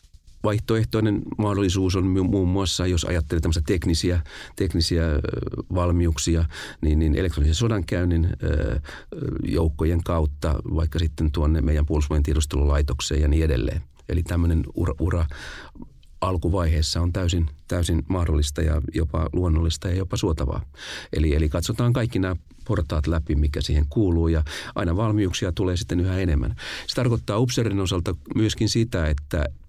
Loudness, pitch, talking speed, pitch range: -24 LUFS, 85 Hz, 135 wpm, 80-95 Hz